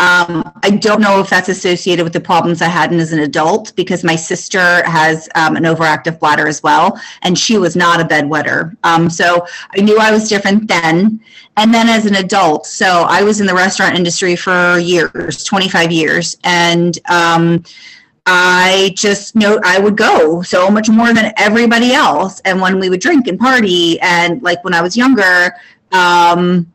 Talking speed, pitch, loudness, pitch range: 190 wpm, 180 Hz, -11 LUFS, 170-205 Hz